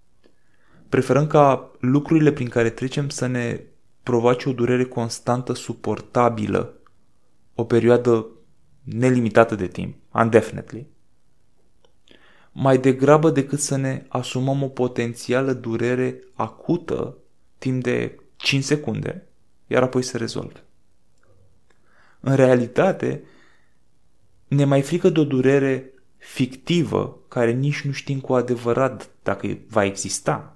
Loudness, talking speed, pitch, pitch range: -21 LUFS, 110 wpm, 125 Hz, 115-135 Hz